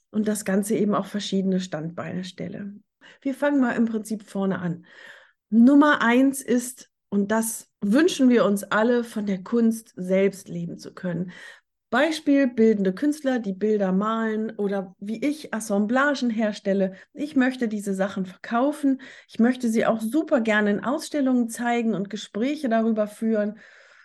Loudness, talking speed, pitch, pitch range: -23 LUFS, 150 wpm, 220 Hz, 200-250 Hz